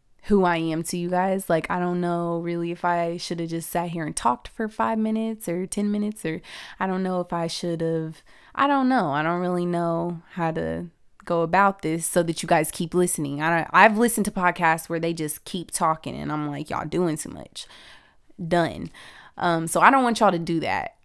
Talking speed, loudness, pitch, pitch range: 230 wpm, -23 LUFS, 170 Hz, 165-185 Hz